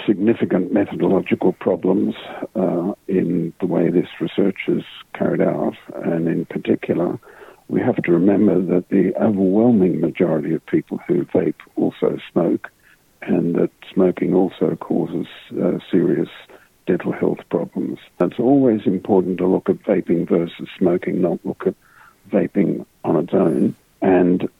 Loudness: -19 LUFS